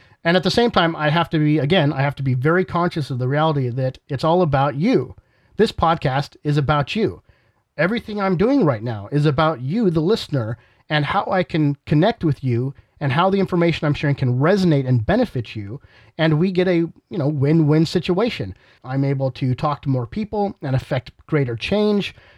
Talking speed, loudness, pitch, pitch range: 205 wpm, -20 LUFS, 150 Hz, 135-180 Hz